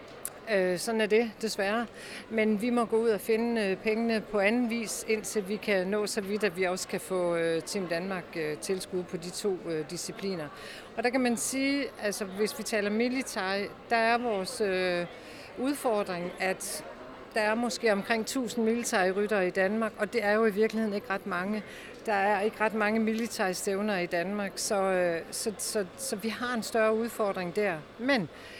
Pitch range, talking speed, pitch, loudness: 190-225 Hz, 180 wpm, 210 Hz, -30 LUFS